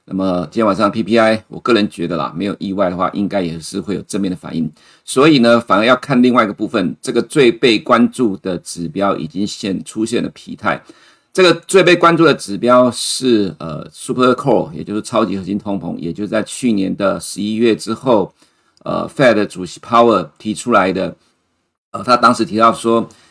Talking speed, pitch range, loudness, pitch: 325 characters per minute, 95-120 Hz, -15 LUFS, 110 Hz